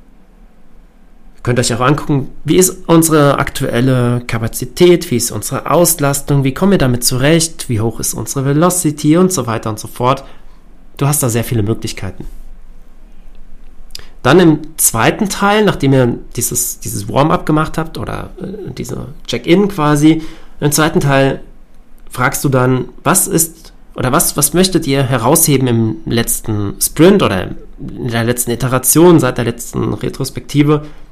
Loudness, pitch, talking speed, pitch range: -13 LUFS, 135 Hz, 150 wpm, 120-155 Hz